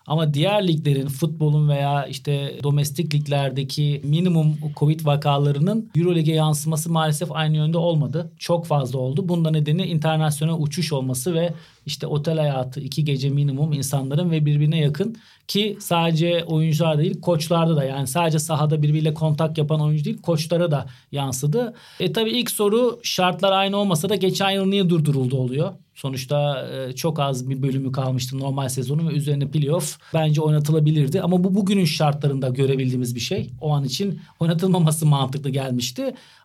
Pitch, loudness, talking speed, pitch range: 155 Hz, -21 LUFS, 150 wpm, 140-170 Hz